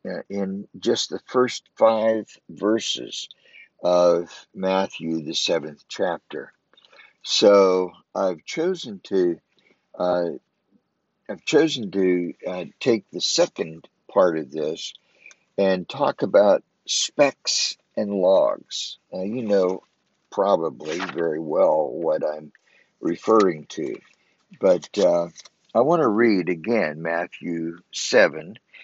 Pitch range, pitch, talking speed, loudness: 85-105 Hz, 90 Hz, 105 wpm, -22 LUFS